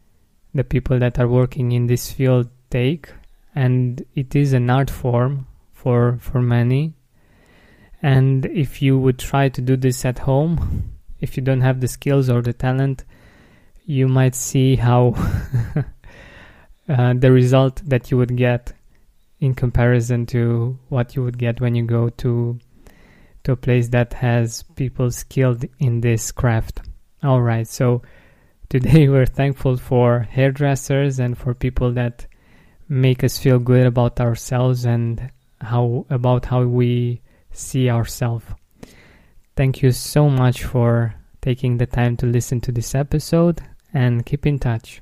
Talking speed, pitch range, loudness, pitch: 150 wpm, 120-130 Hz, -19 LUFS, 125 Hz